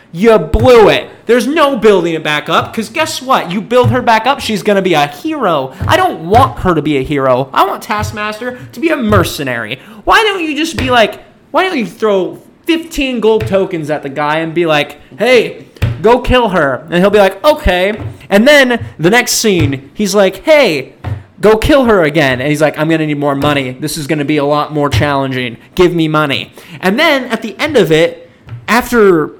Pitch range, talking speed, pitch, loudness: 150-245 Hz, 220 wpm, 190 Hz, -11 LUFS